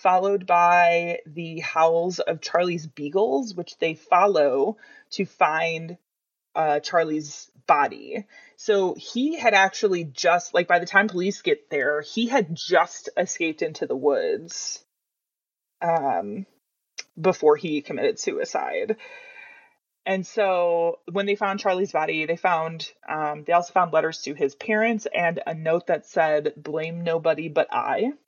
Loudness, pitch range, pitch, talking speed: -23 LUFS, 160-205 Hz, 175 Hz, 140 wpm